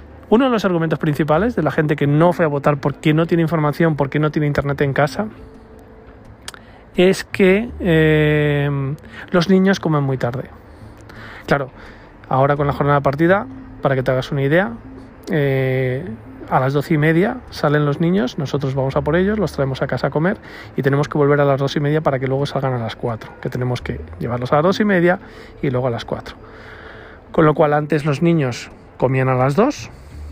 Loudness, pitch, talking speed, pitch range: -18 LUFS, 145 Hz, 205 wpm, 130-165 Hz